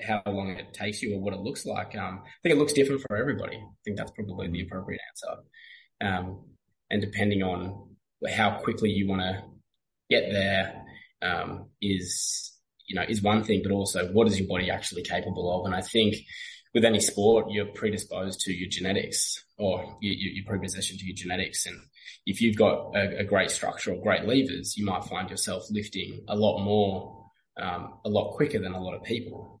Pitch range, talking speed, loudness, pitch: 95-105 Hz, 200 wpm, -28 LUFS, 100 Hz